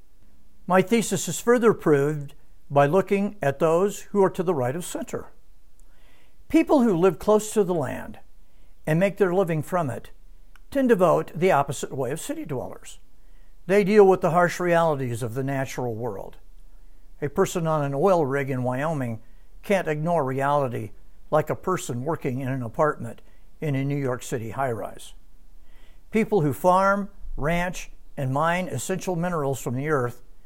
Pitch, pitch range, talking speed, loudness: 155 Hz, 135-190 Hz, 165 wpm, -24 LUFS